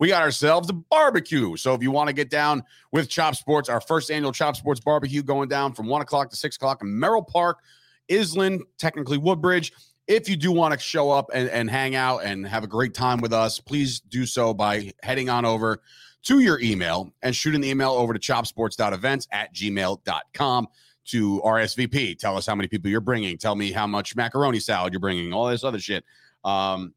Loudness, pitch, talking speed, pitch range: -23 LUFS, 130 Hz, 210 wpm, 110-150 Hz